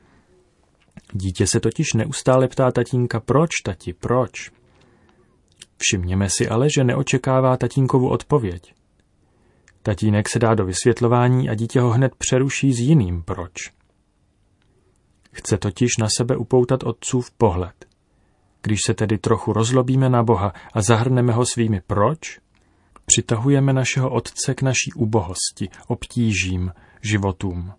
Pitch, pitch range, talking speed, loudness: 115 Hz, 100-130 Hz, 120 wpm, -20 LUFS